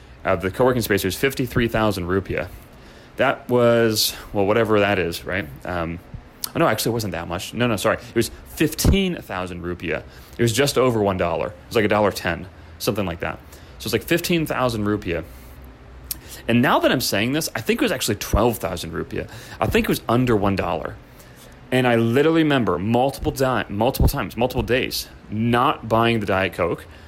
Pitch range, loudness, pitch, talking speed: 90-125 Hz, -21 LUFS, 110 Hz, 185 wpm